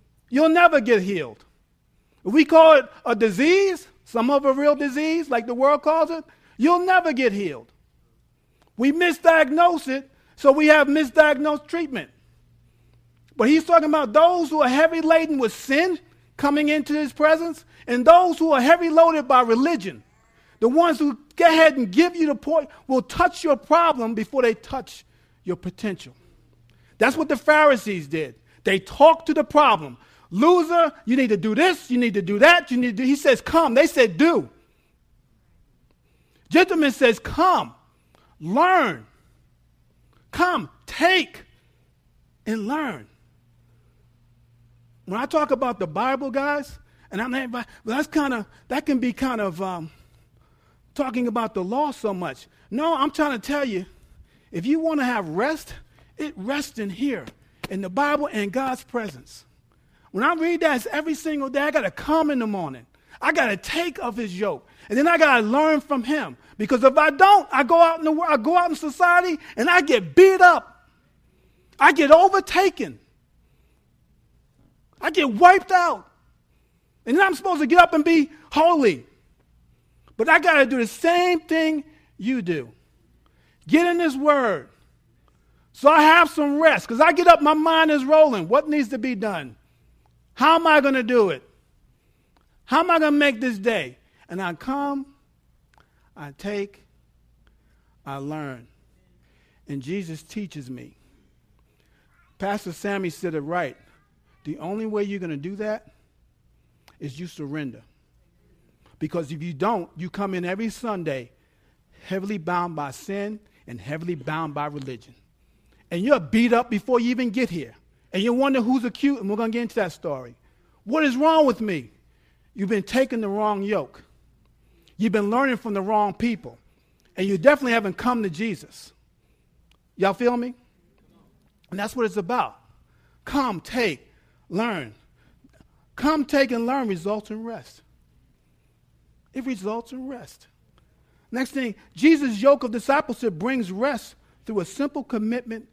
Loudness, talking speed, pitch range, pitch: -20 LUFS, 165 wpm, 195-305 Hz, 255 Hz